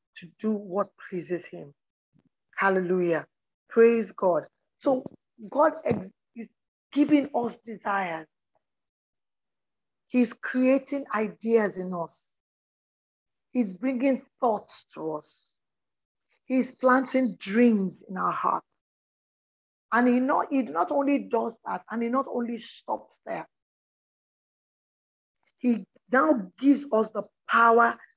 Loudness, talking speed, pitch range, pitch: -26 LUFS, 105 wpm, 200-260 Hz, 230 Hz